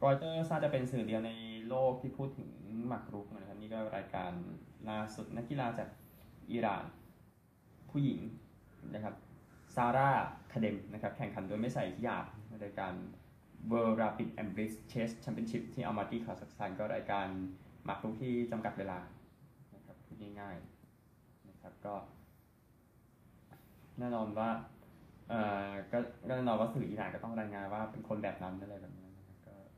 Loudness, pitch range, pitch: -39 LUFS, 100-115 Hz, 110 Hz